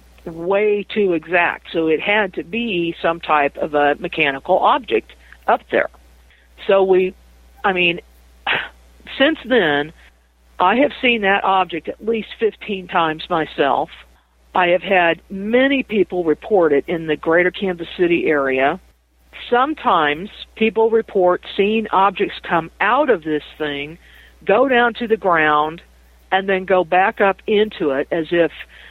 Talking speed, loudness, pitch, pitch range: 145 wpm, -18 LUFS, 180 Hz, 150-205 Hz